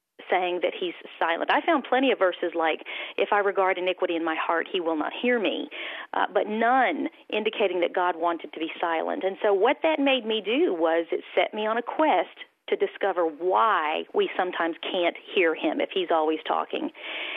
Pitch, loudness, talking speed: 210 Hz, -25 LUFS, 200 wpm